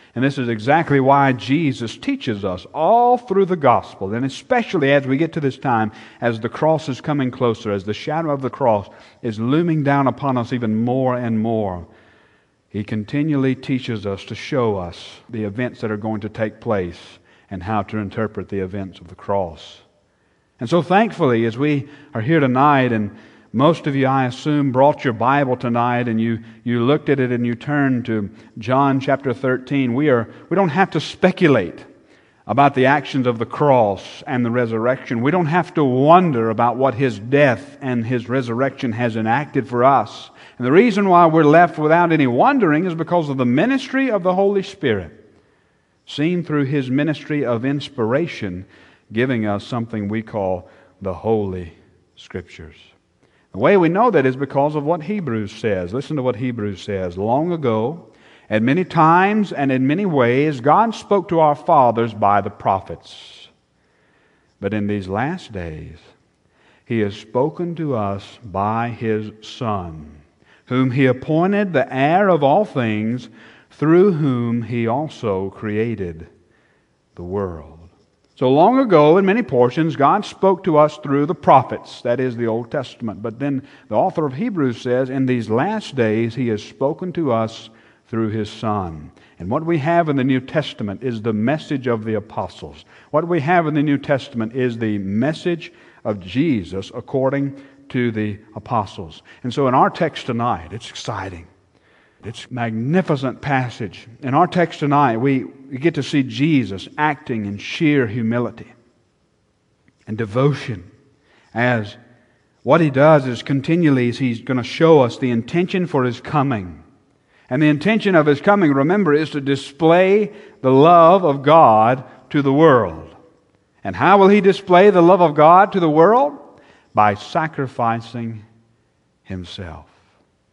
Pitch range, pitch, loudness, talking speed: 110-150 Hz, 125 Hz, -18 LUFS, 165 wpm